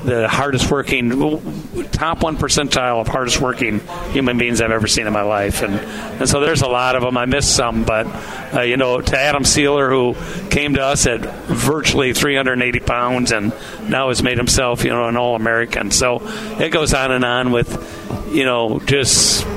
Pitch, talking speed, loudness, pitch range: 125 Hz, 195 wpm, -16 LUFS, 120-140 Hz